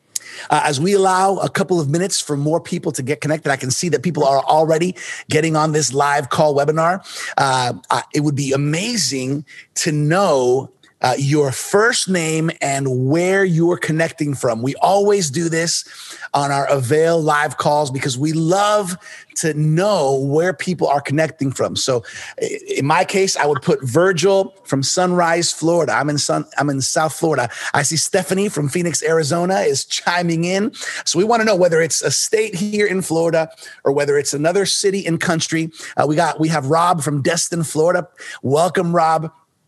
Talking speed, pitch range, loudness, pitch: 180 wpm, 145-180 Hz, -17 LUFS, 160 Hz